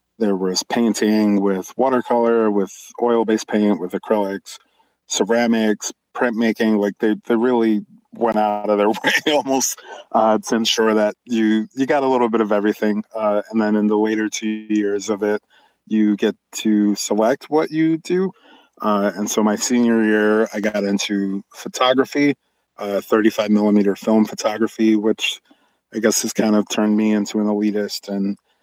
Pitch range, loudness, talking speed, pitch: 105-115 Hz, -19 LUFS, 165 wpm, 110 Hz